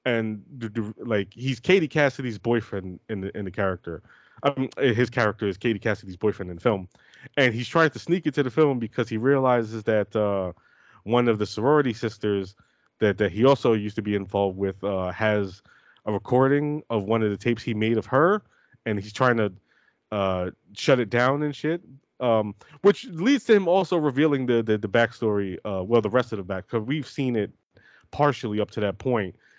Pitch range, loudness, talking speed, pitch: 105-135 Hz, -24 LUFS, 200 wpm, 115 Hz